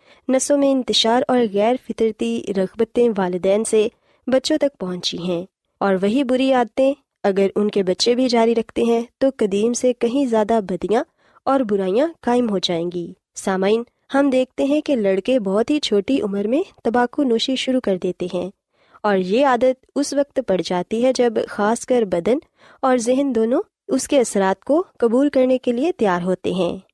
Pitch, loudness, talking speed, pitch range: 235 Hz, -19 LUFS, 180 wpm, 200-260 Hz